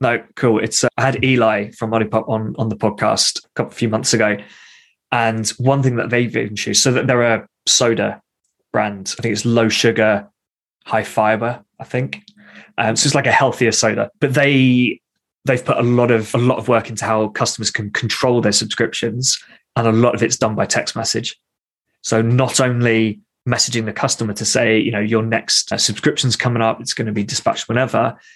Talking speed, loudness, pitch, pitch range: 205 wpm, -17 LUFS, 115 Hz, 110-125 Hz